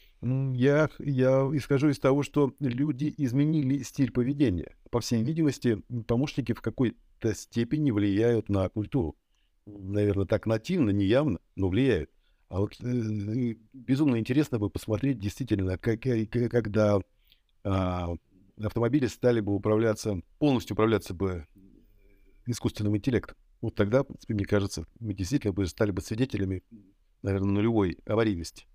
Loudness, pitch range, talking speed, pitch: -28 LUFS, 100-130 Hz, 130 wpm, 110 Hz